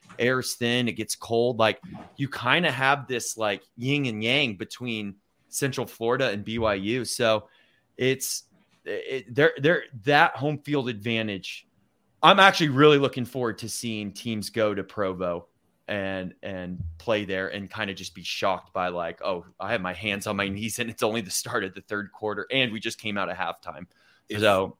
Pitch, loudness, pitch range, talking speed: 115 Hz, -25 LUFS, 100-130 Hz, 185 wpm